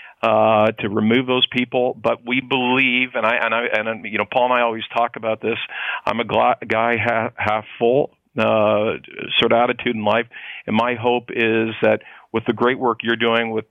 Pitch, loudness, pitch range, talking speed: 115 Hz, -19 LUFS, 110-125 Hz, 205 wpm